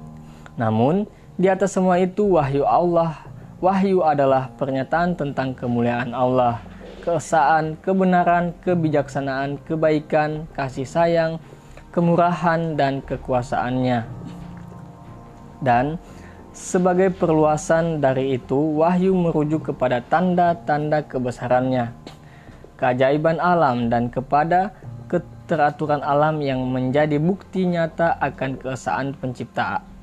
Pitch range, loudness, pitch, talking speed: 130-170 Hz, -21 LUFS, 145 Hz, 90 wpm